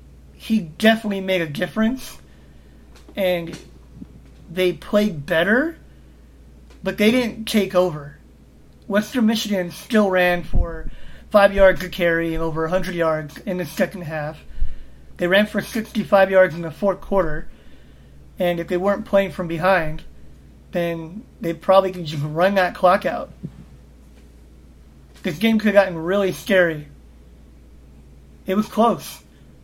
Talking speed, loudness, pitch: 135 wpm, -20 LUFS, 175 Hz